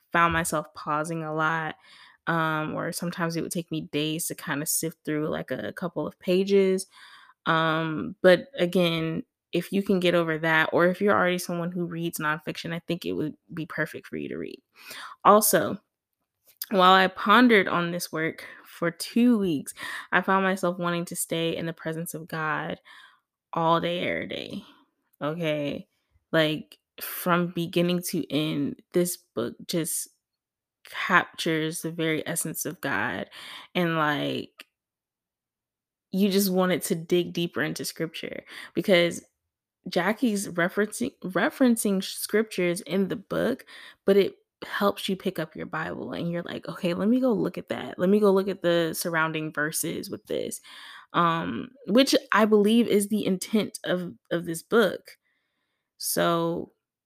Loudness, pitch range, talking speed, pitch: -26 LUFS, 160-195 Hz, 155 wpm, 175 Hz